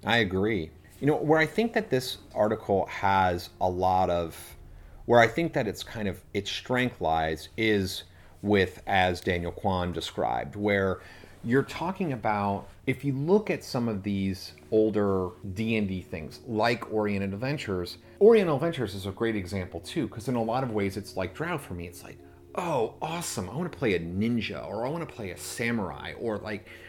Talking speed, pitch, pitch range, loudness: 190 wpm, 100 Hz, 90-120 Hz, -28 LUFS